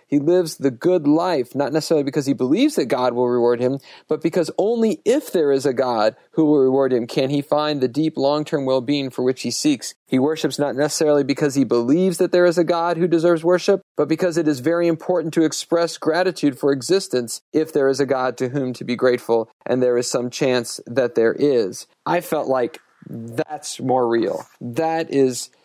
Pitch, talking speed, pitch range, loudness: 150 Hz, 215 wpm, 130-170 Hz, -20 LUFS